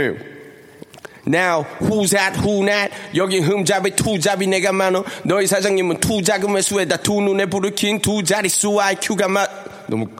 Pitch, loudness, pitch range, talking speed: 200 Hz, -18 LUFS, 190-205 Hz, 530 characters per minute